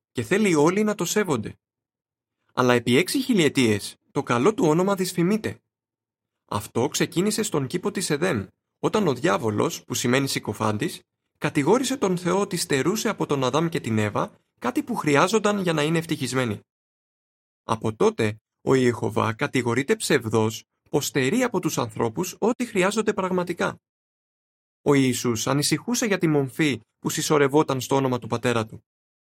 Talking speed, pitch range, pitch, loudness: 145 wpm, 120-180 Hz, 145 Hz, -23 LUFS